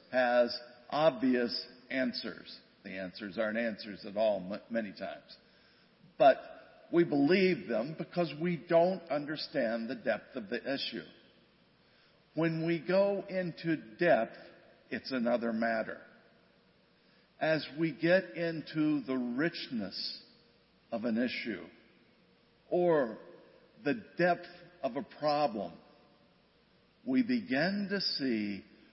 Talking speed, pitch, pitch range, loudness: 110 wpm, 155 Hz, 120-175 Hz, -33 LUFS